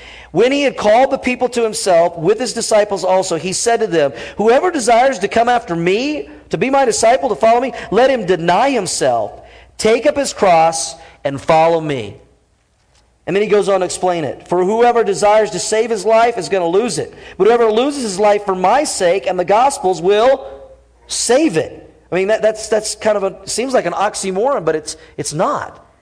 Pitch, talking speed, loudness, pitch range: 210 Hz, 210 wpm, -15 LUFS, 180-235 Hz